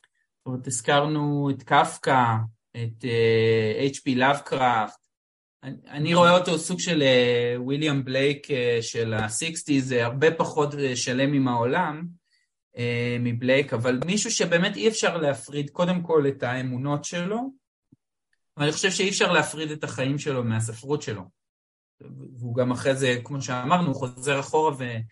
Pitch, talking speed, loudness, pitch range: 140 Hz, 145 wpm, -24 LUFS, 120-155 Hz